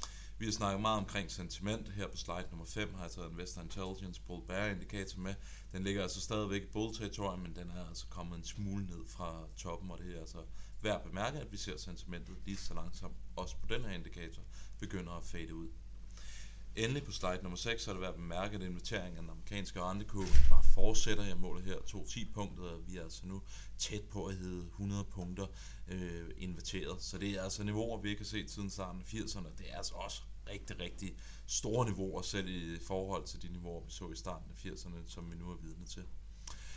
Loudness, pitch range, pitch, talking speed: -42 LUFS, 85-100 Hz, 95 Hz, 220 wpm